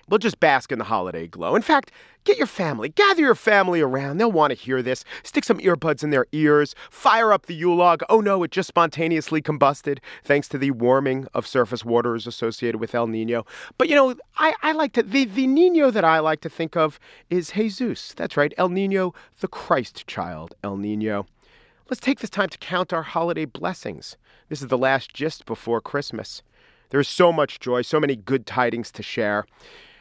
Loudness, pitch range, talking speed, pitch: -22 LUFS, 130-205 Hz, 205 wpm, 155 Hz